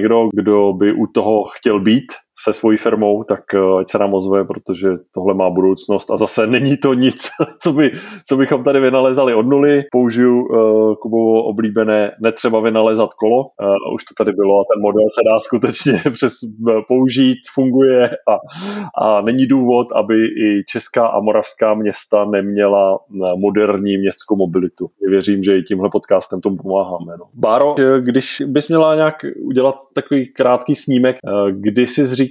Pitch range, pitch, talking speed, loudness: 100-130 Hz, 110 Hz, 160 wpm, -15 LUFS